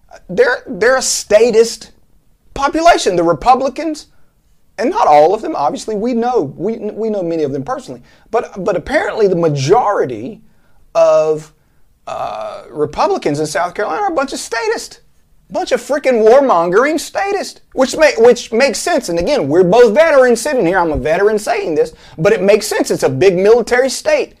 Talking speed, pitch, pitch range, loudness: 170 wpm, 240 Hz, 200-305 Hz, -13 LUFS